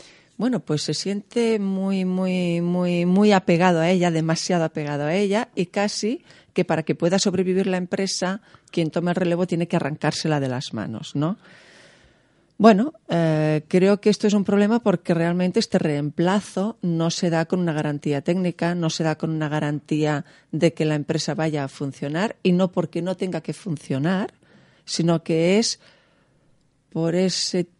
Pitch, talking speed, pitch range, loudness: 175 Hz, 170 wpm, 160-190 Hz, -22 LUFS